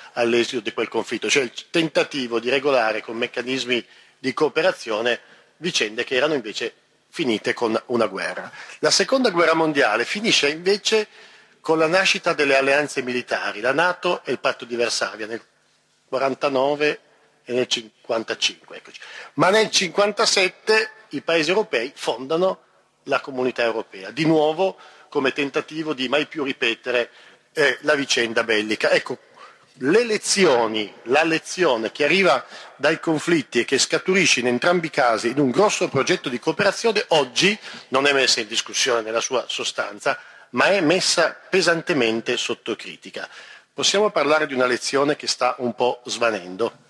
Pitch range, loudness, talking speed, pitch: 125-180 Hz, -21 LUFS, 145 wpm, 145 Hz